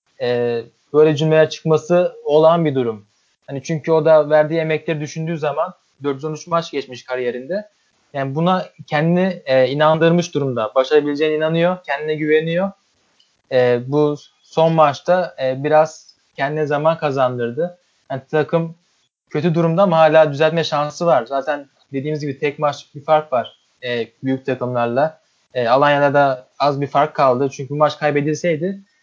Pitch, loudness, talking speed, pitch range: 150 Hz, -18 LUFS, 140 wpm, 135-160 Hz